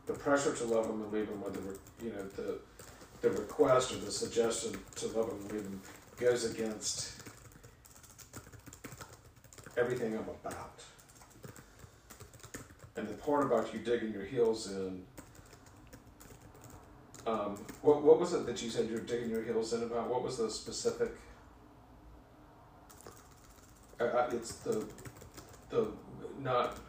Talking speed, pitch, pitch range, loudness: 135 wpm, 115 Hz, 105-125 Hz, -35 LUFS